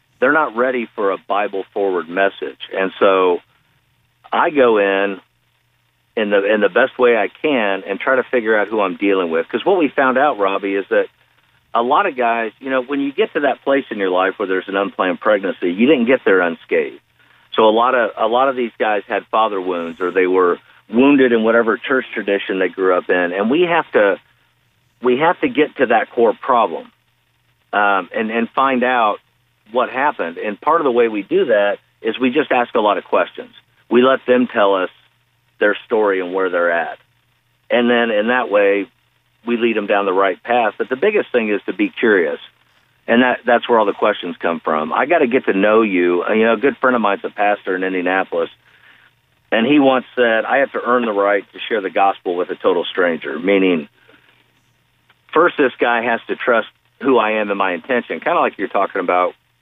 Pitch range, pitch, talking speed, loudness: 100-135 Hz, 115 Hz, 220 wpm, -16 LUFS